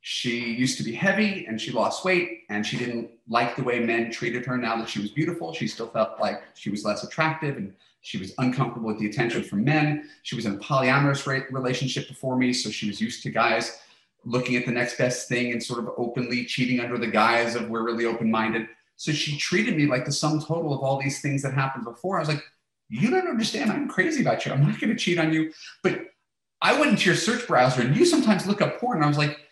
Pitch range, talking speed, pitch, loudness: 120-155 Hz, 245 wpm, 125 Hz, -25 LUFS